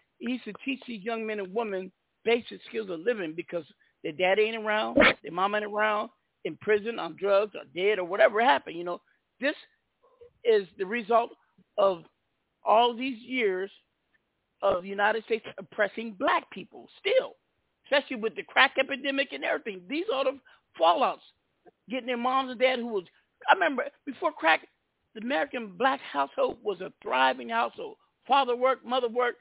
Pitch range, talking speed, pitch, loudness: 200-265 Hz, 170 wpm, 235 Hz, -28 LUFS